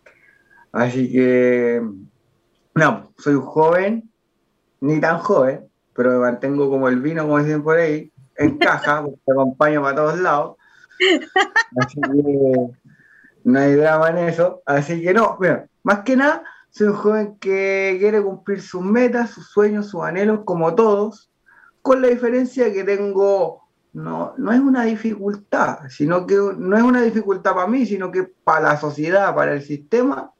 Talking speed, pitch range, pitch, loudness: 160 wpm, 145-215 Hz, 185 Hz, -18 LUFS